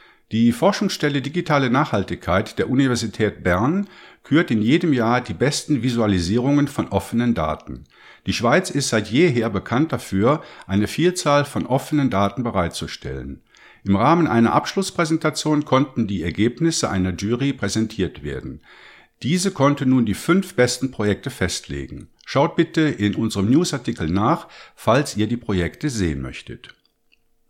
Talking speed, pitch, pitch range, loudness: 135 wpm, 120 Hz, 100-145 Hz, -20 LUFS